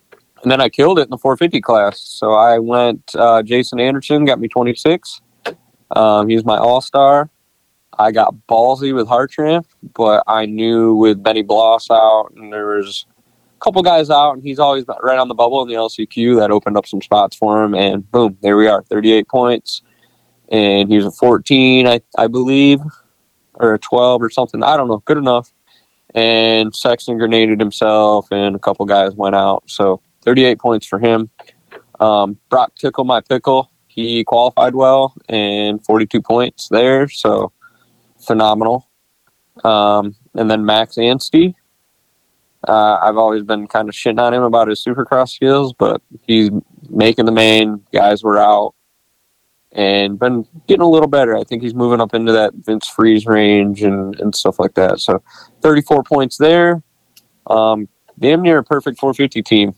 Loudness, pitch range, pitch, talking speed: -13 LUFS, 105-130 Hz, 115 Hz, 170 wpm